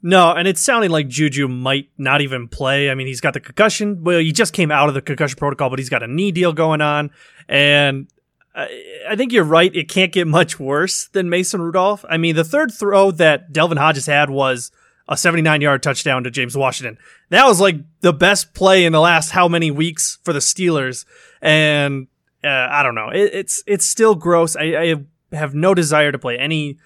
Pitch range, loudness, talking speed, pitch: 145-180 Hz, -15 LUFS, 215 wpm, 160 Hz